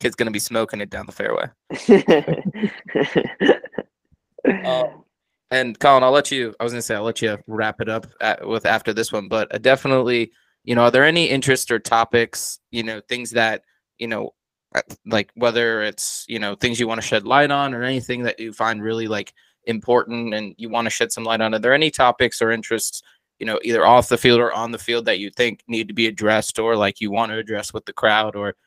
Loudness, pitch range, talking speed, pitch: -20 LUFS, 110-120 Hz, 230 wpm, 115 Hz